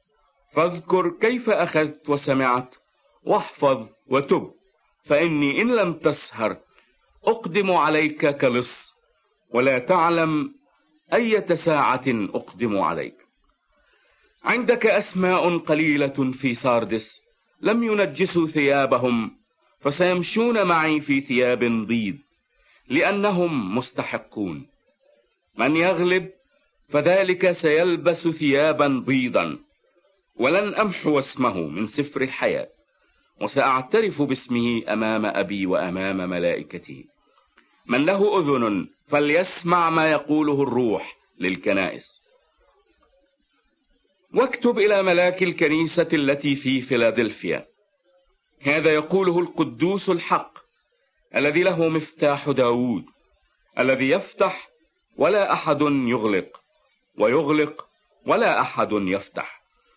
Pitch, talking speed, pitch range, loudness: 160 Hz, 85 wpm, 140-190 Hz, -22 LUFS